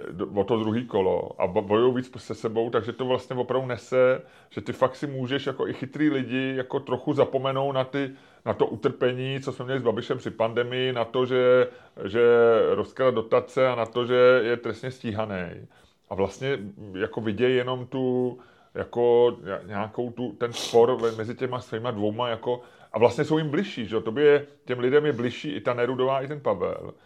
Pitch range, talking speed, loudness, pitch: 115-130 Hz, 190 wpm, -25 LUFS, 125 Hz